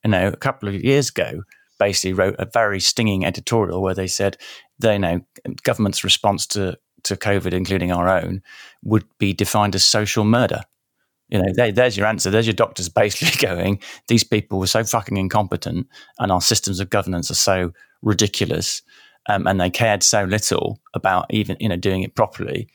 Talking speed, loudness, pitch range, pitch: 185 wpm, -19 LUFS, 95-110 Hz, 100 Hz